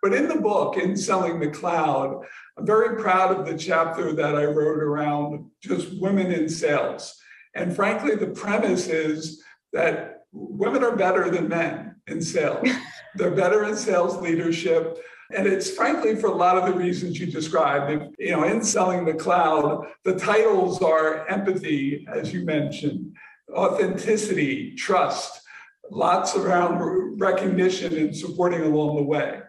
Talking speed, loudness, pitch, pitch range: 150 wpm, -23 LUFS, 180 Hz, 155-190 Hz